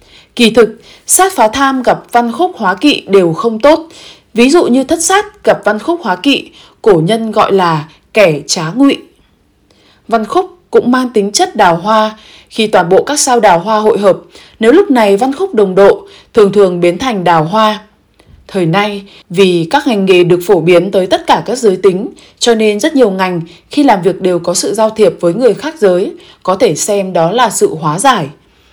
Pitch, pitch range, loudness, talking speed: 215 Hz, 185-275 Hz, -10 LUFS, 210 wpm